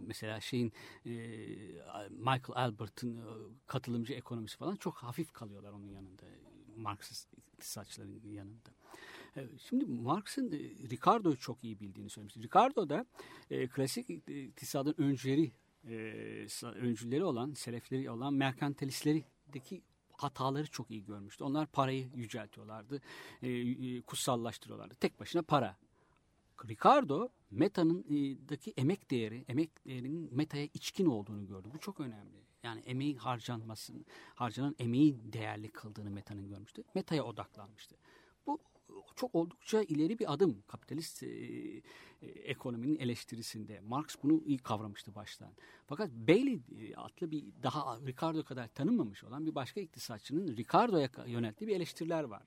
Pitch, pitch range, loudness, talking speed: 125 Hz, 110-150 Hz, -37 LUFS, 115 wpm